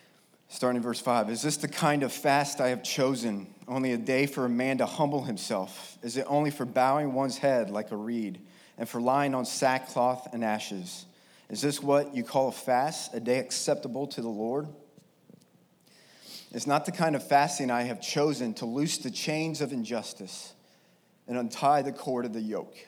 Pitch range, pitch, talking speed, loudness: 120-145 Hz, 130 Hz, 195 wpm, -29 LUFS